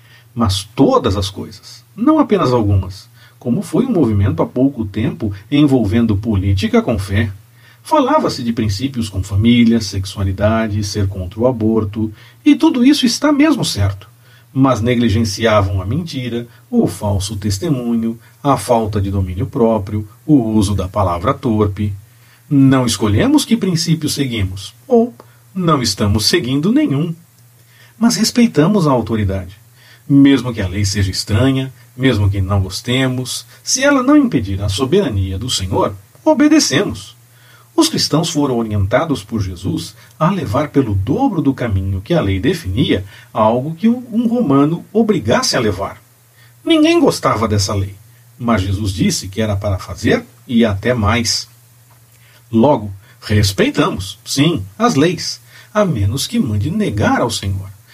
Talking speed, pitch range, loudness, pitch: 140 wpm, 105-135 Hz, -15 LUFS, 120 Hz